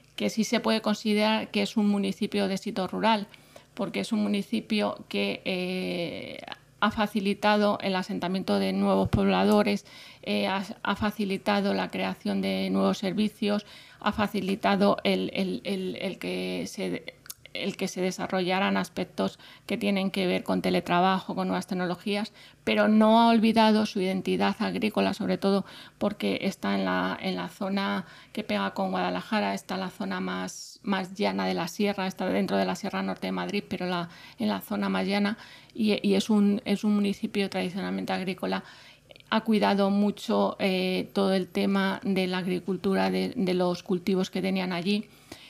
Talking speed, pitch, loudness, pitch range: 170 wpm, 195 Hz, -27 LUFS, 180-205 Hz